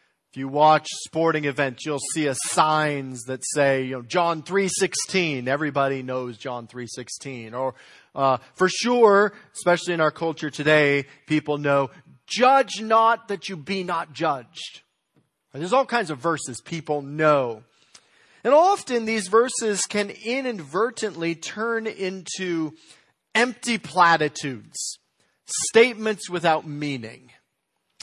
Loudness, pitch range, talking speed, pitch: -23 LUFS, 140-205 Hz, 125 wpm, 160 Hz